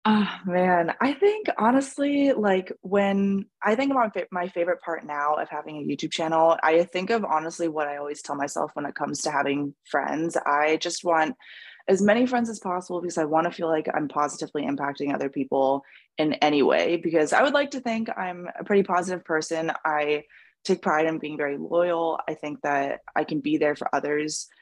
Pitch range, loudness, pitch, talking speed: 150-190 Hz, -25 LUFS, 165 Hz, 200 wpm